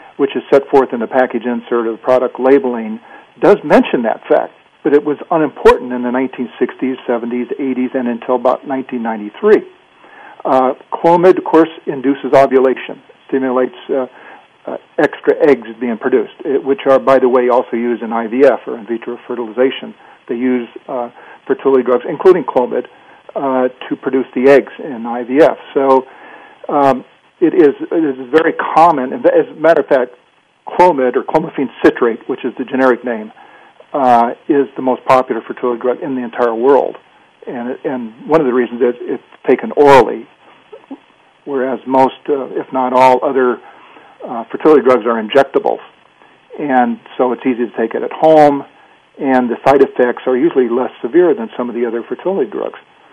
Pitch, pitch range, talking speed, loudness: 130 Hz, 125-150 Hz, 170 wpm, -14 LUFS